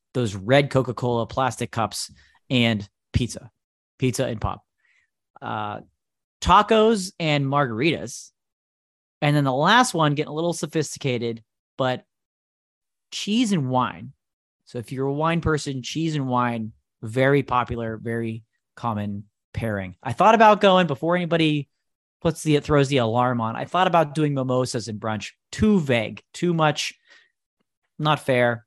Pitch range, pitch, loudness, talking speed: 115-155 Hz, 130 Hz, -22 LUFS, 140 wpm